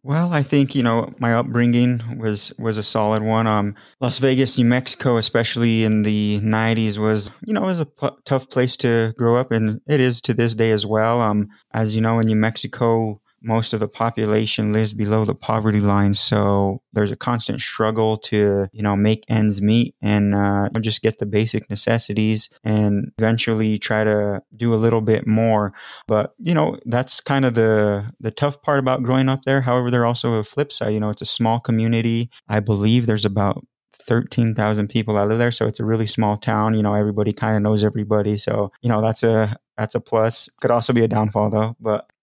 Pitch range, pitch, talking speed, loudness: 105-120 Hz, 110 Hz, 210 wpm, -19 LUFS